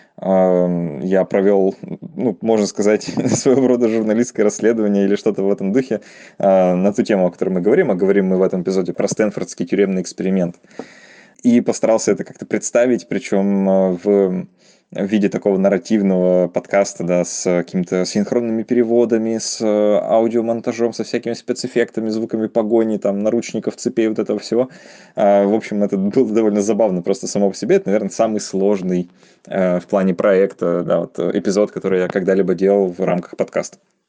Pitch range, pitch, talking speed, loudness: 95-115 Hz, 100 Hz, 155 wpm, -17 LUFS